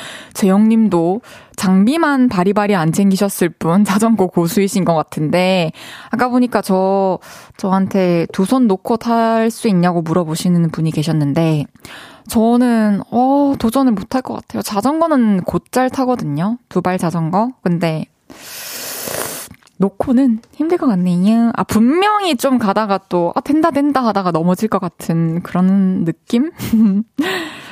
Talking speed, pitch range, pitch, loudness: 265 characters per minute, 180-245 Hz, 200 Hz, -15 LUFS